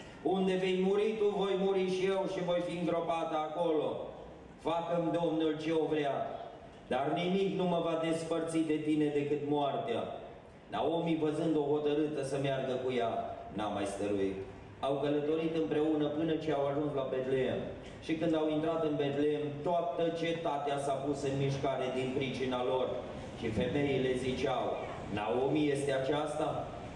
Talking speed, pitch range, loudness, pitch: 155 wpm, 135-165 Hz, -33 LUFS, 150 Hz